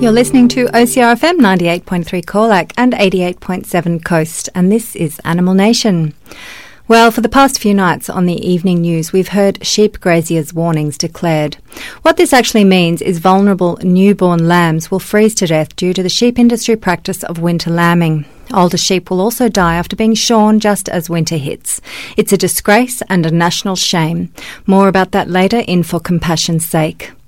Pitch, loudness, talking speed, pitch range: 185 Hz, -12 LUFS, 170 wpm, 170-215 Hz